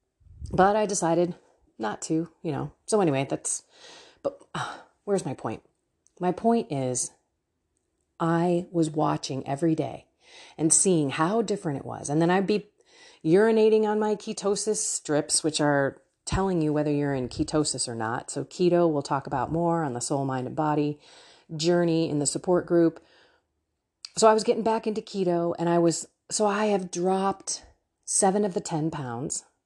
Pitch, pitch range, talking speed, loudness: 170 Hz, 150-205 Hz, 170 wpm, -26 LUFS